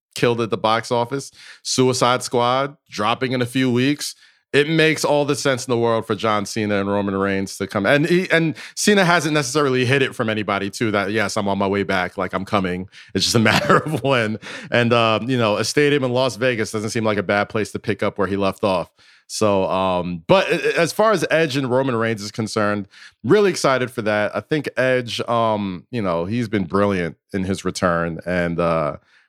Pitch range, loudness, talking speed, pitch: 100-130 Hz, -19 LUFS, 220 wpm, 115 Hz